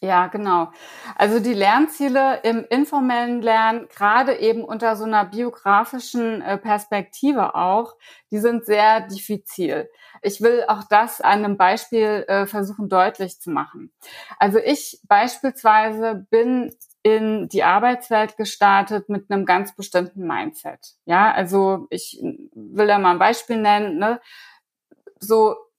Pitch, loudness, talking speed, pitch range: 220 Hz, -19 LUFS, 130 wpm, 200-240 Hz